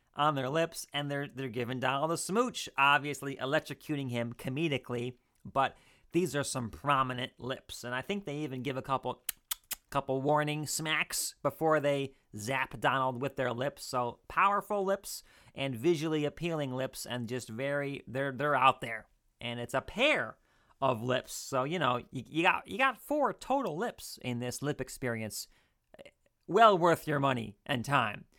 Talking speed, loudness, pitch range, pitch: 165 wpm, -32 LUFS, 125-155 Hz, 140 Hz